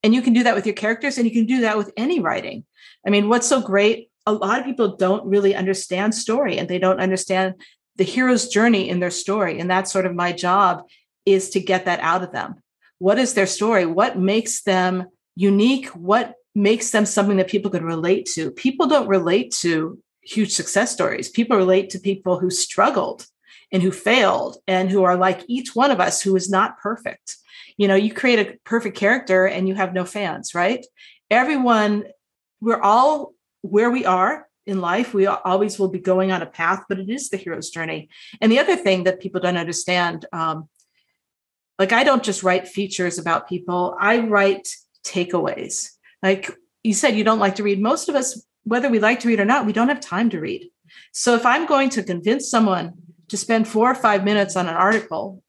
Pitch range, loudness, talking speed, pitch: 185-230 Hz, -19 LUFS, 210 wpm, 200 Hz